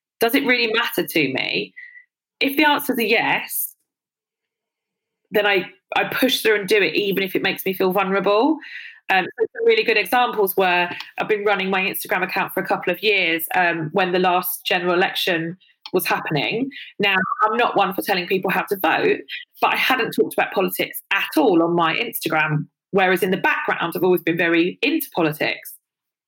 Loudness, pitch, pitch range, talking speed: -19 LUFS, 195 Hz, 180-245 Hz, 185 wpm